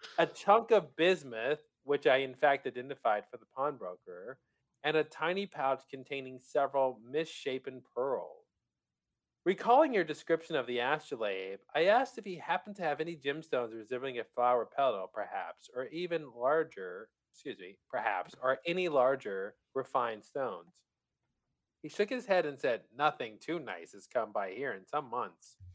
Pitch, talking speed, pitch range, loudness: 155 Hz, 155 wpm, 135-205 Hz, -34 LUFS